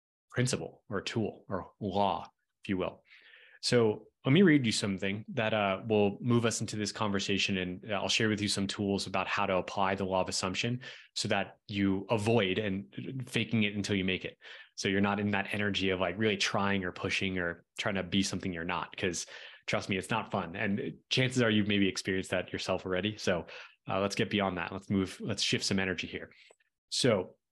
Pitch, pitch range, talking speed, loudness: 100 Hz, 95-110 Hz, 210 wpm, -31 LUFS